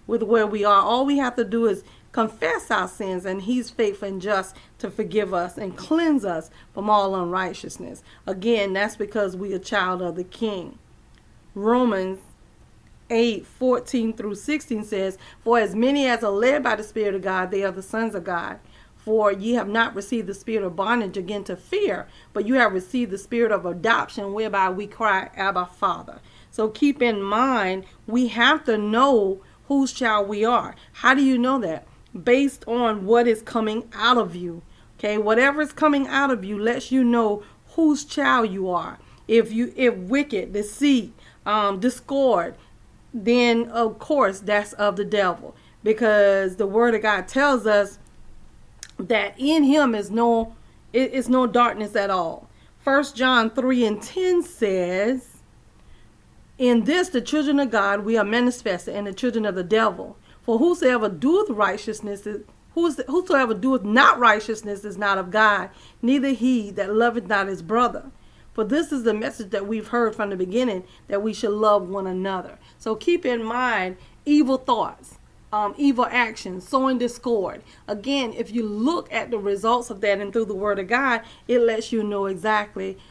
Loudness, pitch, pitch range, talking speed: -22 LUFS, 225 Hz, 200-245 Hz, 175 wpm